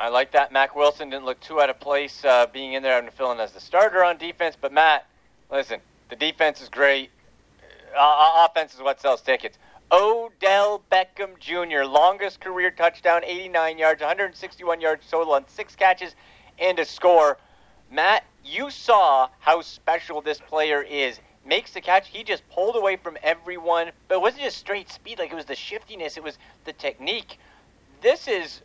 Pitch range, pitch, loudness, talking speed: 140-185 Hz, 165 Hz, -22 LUFS, 185 wpm